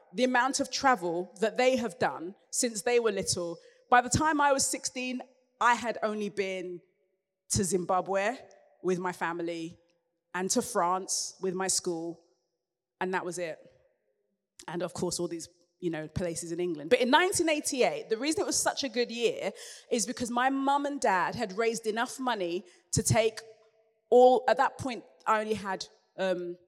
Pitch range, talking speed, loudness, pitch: 180-250 Hz, 175 wpm, -29 LUFS, 210 Hz